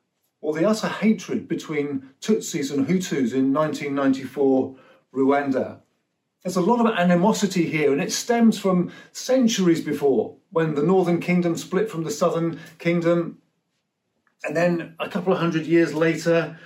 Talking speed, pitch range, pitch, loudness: 145 wpm, 150-185 Hz, 165 Hz, -22 LUFS